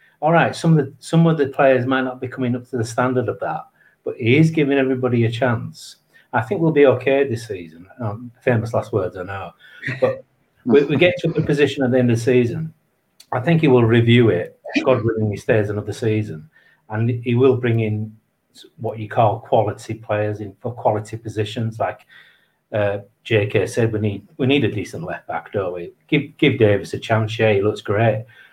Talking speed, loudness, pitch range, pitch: 210 wpm, -19 LUFS, 110-135 Hz, 120 Hz